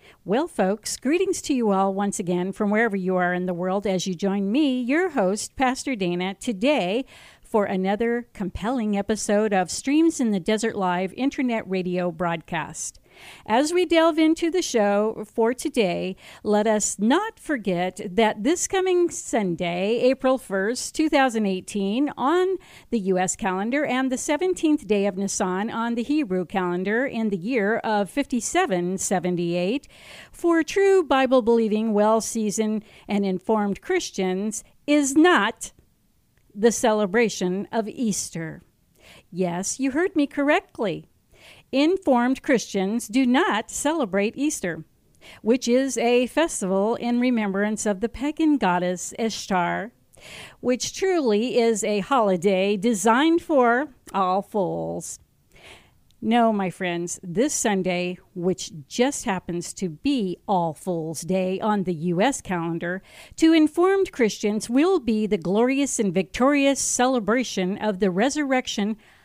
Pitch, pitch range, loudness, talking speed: 220 Hz, 190-265 Hz, -23 LUFS, 130 wpm